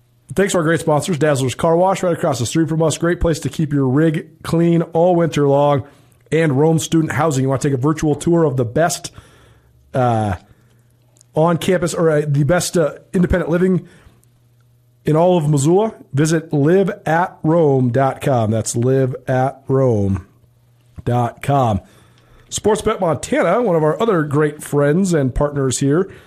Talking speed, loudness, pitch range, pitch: 160 wpm, -17 LUFS, 125-165 Hz, 150 Hz